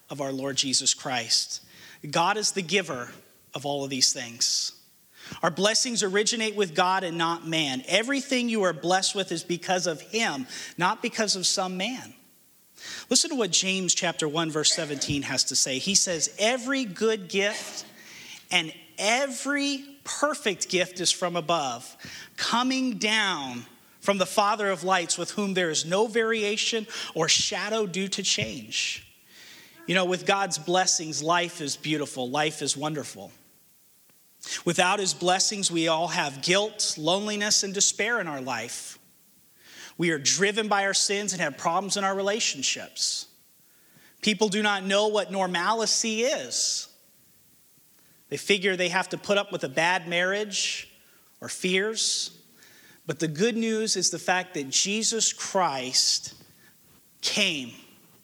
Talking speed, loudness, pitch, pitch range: 150 wpm, -25 LUFS, 190 Hz, 165-210 Hz